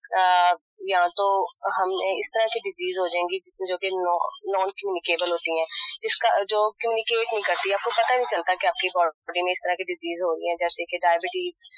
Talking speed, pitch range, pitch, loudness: 230 wpm, 175-215 Hz, 185 Hz, -23 LUFS